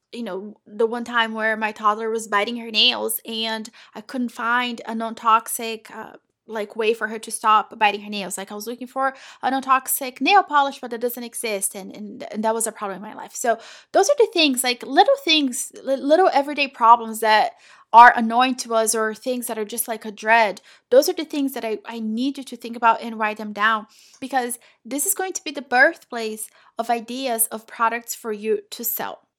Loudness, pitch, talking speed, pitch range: -20 LUFS, 230 Hz, 220 wpm, 220-260 Hz